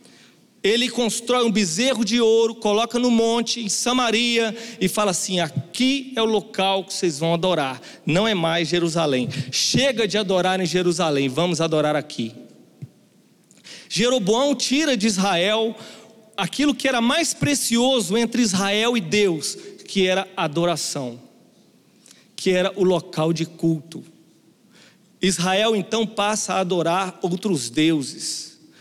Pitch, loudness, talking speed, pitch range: 195 Hz, -21 LUFS, 135 wpm, 170-230 Hz